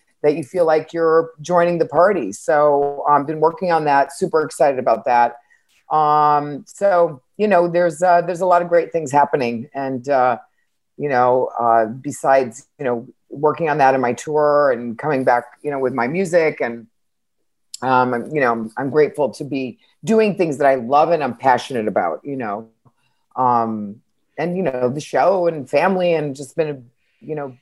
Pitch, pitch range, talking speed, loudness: 145 Hz, 125-165 Hz, 190 wpm, -18 LUFS